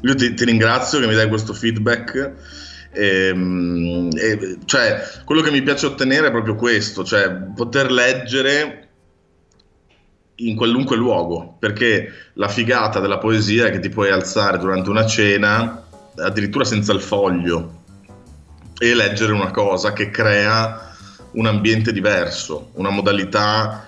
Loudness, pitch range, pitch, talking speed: -17 LUFS, 95-115 Hz, 105 Hz, 135 wpm